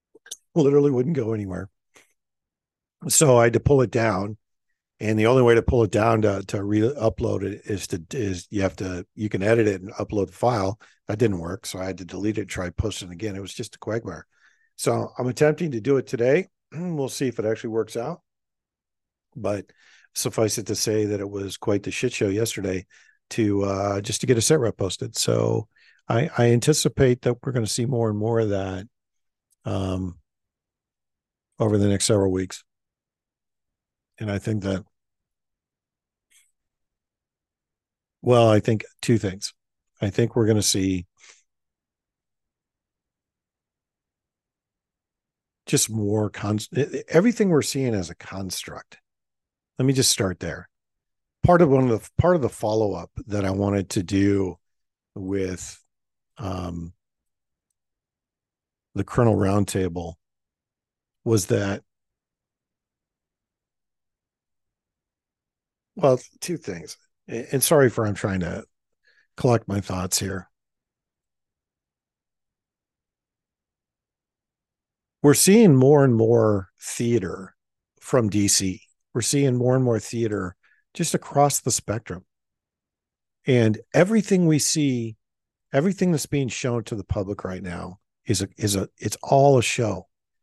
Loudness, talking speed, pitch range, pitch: -22 LUFS, 140 wpm, 95-125 Hz, 110 Hz